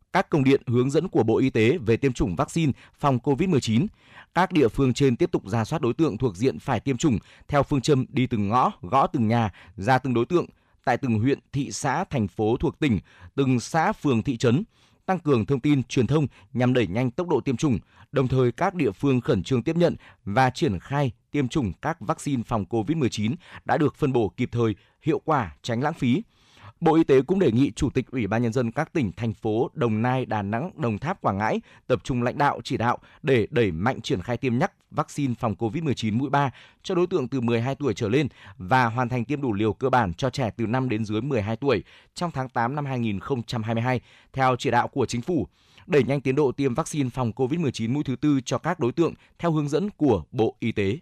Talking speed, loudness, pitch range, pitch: 235 wpm, -24 LUFS, 115-145 Hz, 130 Hz